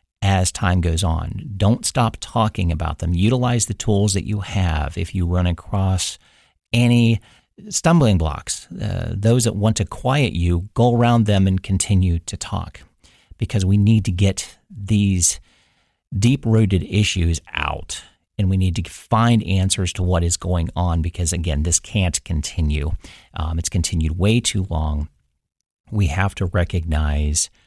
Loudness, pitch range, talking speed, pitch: -20 LUFS, 85-105 Hz, 155 wpm, 95 Hz